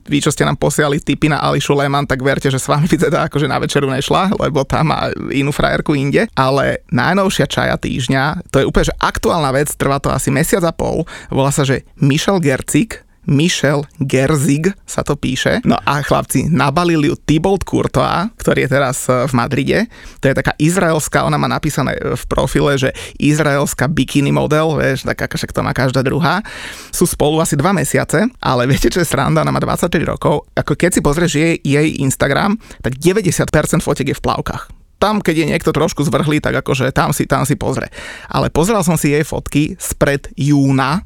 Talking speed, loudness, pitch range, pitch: 190 wpm, -15 LUFS, 140-165 Hz, 150 Hz